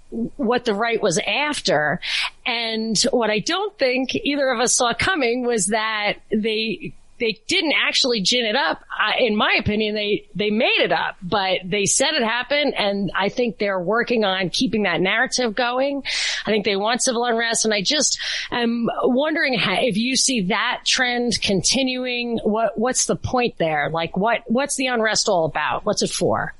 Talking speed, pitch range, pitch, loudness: 185 wpm, 210-255 Hz, 230 Hz, -20 LUFS